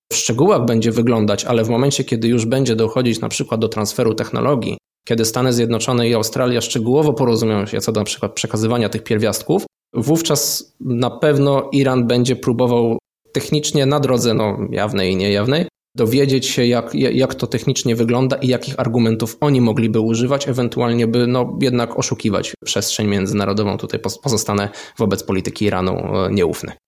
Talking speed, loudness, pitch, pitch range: 155 wpm, -17 LUFS, 120 Hz, 110-130 Hz